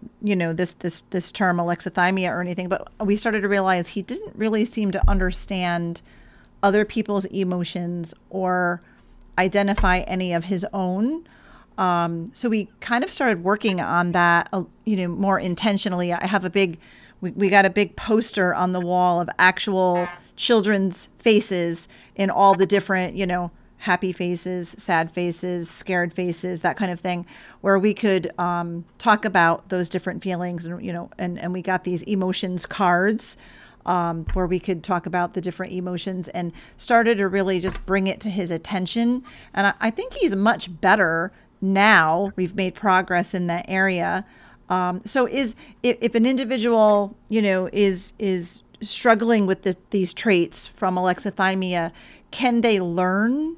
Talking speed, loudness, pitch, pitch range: 165 wpm, -22 LUFS, 185 Hz, 180-205 Hz